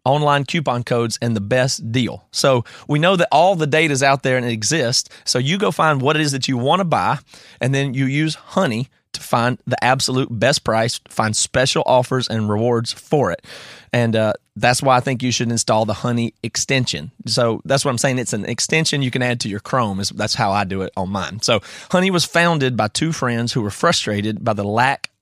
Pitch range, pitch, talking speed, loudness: 115-135 Hz, 125 Hz, 230 wpm, -18 LUFS